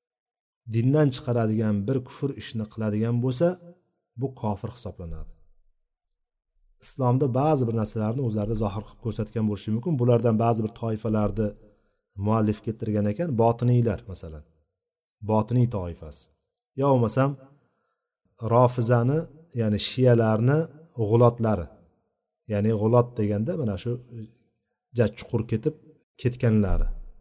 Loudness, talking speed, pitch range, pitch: -25 LUFS, 105 wpm, 105-125 Hz, 115 Hz